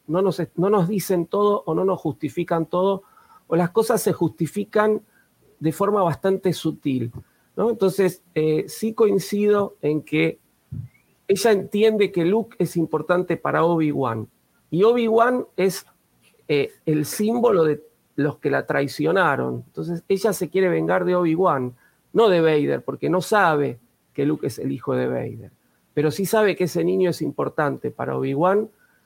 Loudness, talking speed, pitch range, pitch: -22 LUFS, 155 wpm, 155-205 Hz, 180 Hz